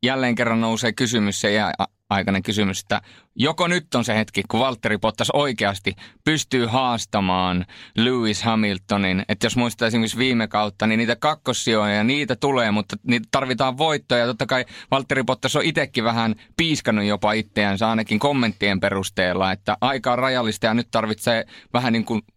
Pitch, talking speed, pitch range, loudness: 115 Hz, 165 wpm, 105-130 Hz, -21 LUFS